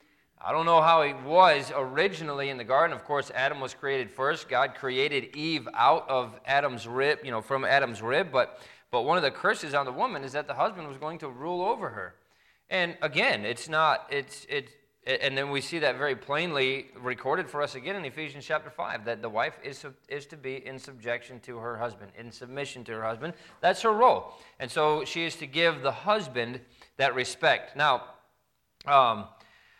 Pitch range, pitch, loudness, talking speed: 130-160 Hz, 140 Hz, -27 LUFS, 205 wpm